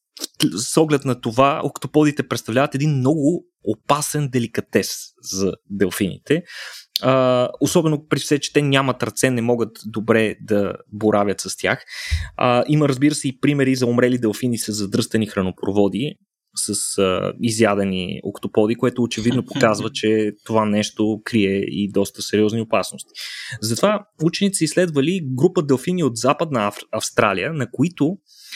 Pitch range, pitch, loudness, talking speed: 105-145 Hz, 125 Hz, -20 LUFS, 130 wpm